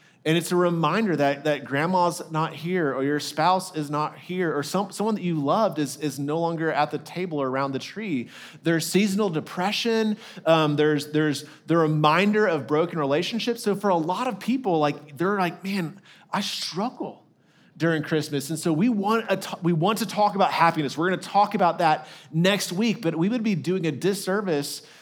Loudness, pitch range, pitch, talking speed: -24 LUFS, 150-195 Hz, 165 Hz, 200 wpm